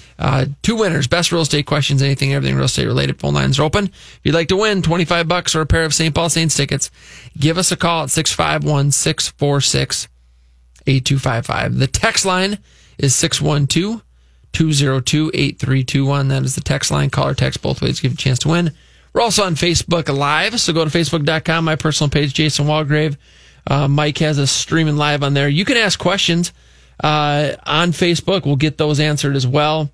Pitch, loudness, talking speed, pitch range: 150 Hz, -16 LUFS, 195 wpm, 140-165 Hz